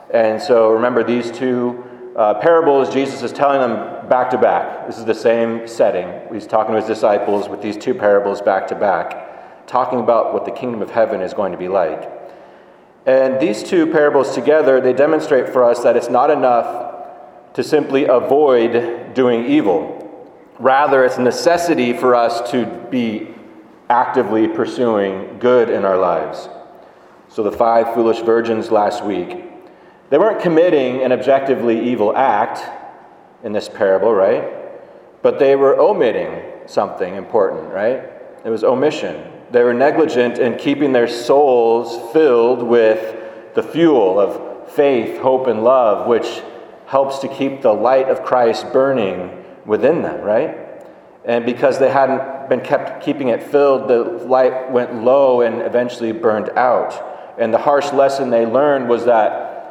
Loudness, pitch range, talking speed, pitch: -15 LUFS, 115-135 Hz, 155 wpm, 125 Hz